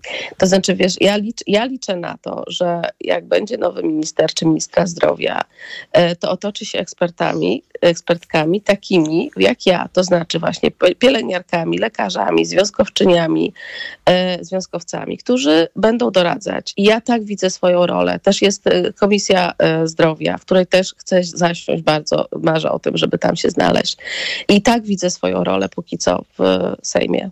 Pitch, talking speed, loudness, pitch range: 185 Hz, 145 wpm, -17 LUFS, 170-220 Hz